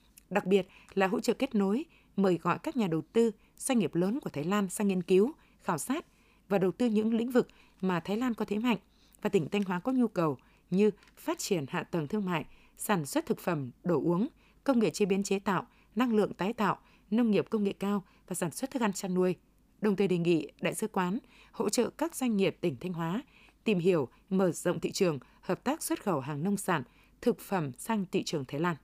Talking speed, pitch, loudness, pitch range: 235 wpm, 200 Hz, -31 LUFS, 180-225 Hz